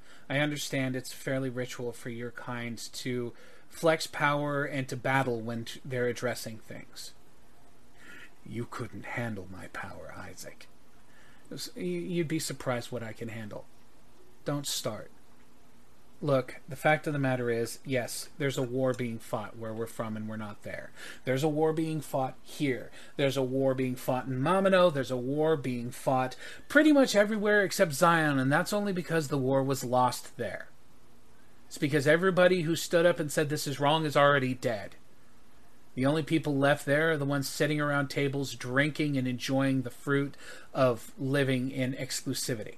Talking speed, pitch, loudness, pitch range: 170 wpm, 135 Hz, -30 LUFS, 125-155 Hz